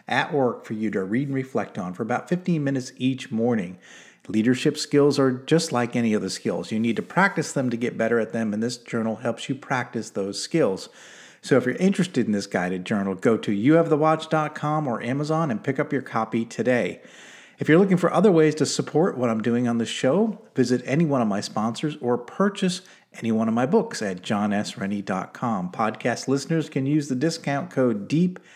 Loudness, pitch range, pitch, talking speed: -24 LUFS, 115-155 Hz, 130 Hz, 205 wpm